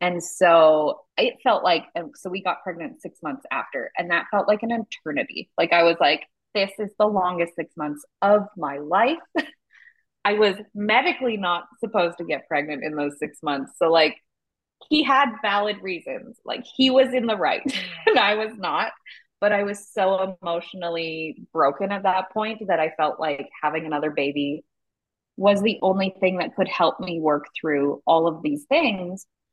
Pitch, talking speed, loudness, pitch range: 185 Hz, 180 wpm, -23 LUFS, 160-215 Hz